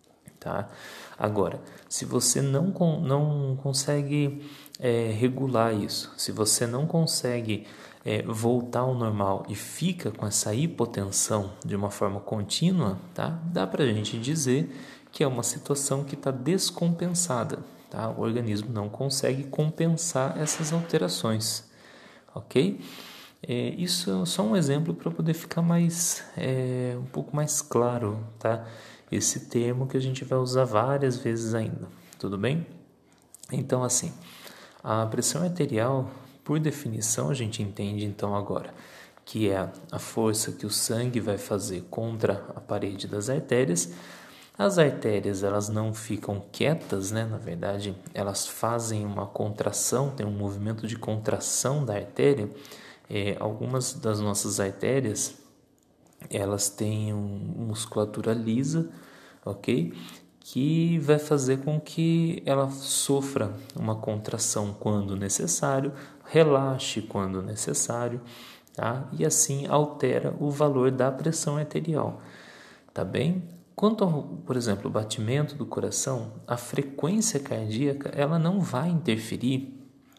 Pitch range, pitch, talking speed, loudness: 105-145 Hz, 125 Hz, 130 wpm, -27 LUFS